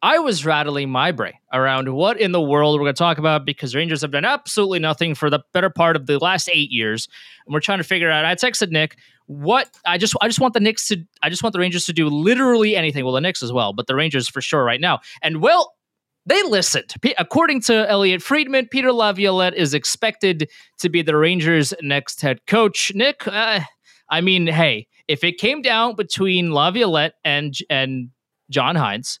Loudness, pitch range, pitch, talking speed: -18 LUFS, 145-210 Hz, 170 Hz, 215 wpm